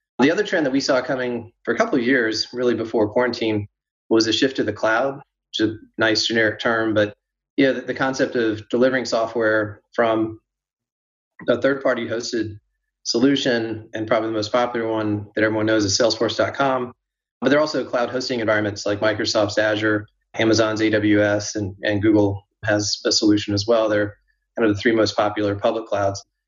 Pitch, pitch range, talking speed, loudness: 110 Hz, 105-125 Hz, 180 wpm, -20 LUFS